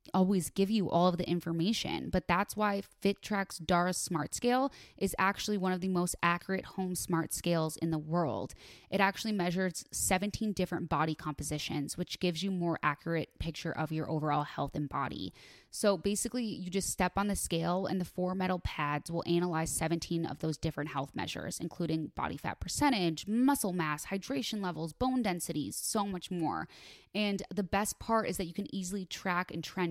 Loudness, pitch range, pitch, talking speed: -33 LUFS, 165-195 Hz, 180 Hz, 185 wpm